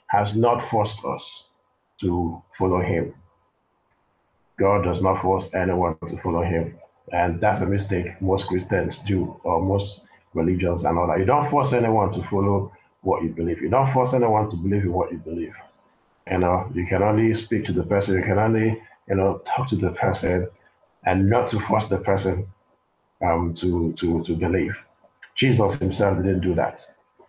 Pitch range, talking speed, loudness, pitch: 90-105 Hz, 180 wpm, -23 LUFS, 95 Hz